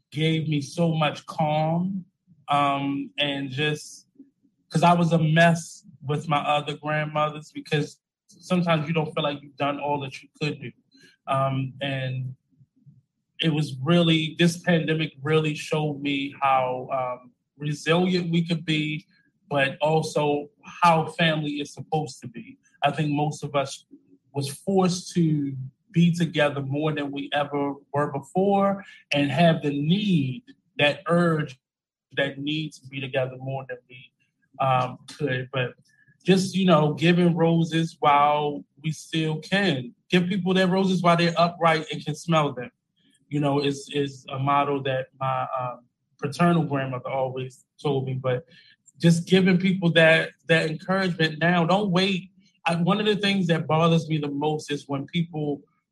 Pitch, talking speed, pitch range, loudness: 150 Hz, 155 wpm, 140-170 Hz, -24 LUFS